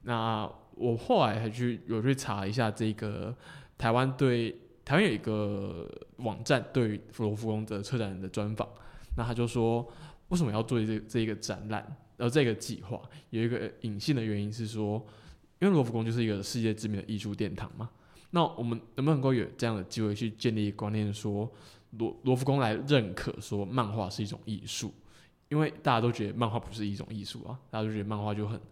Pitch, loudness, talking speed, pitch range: 110 Hz, -32 LUFS, 300 characters per minute, 105-125 Hz